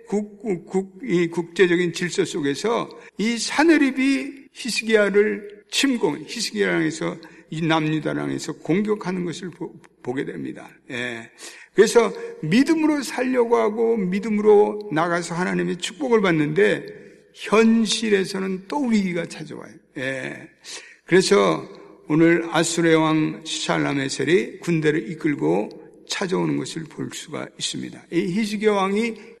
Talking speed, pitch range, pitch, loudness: 275 characters per minute, 165-225 Hz, 195 Hz, -21 LUFS